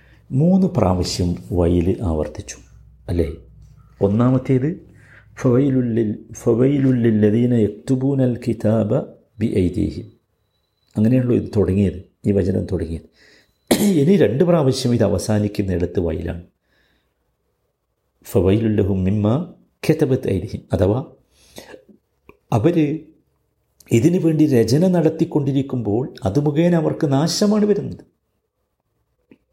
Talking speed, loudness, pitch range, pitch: 80 wpm, -19 LUFS, 100-140 Hz, 115 Hz